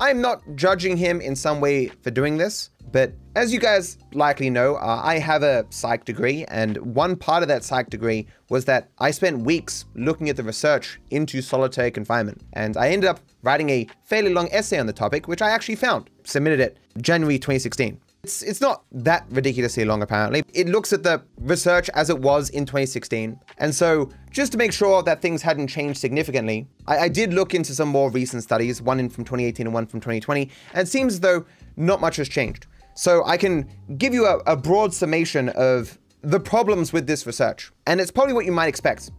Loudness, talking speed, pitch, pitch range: -22 LUFS, 210 wpm, 150 Hz, 125-180 Hz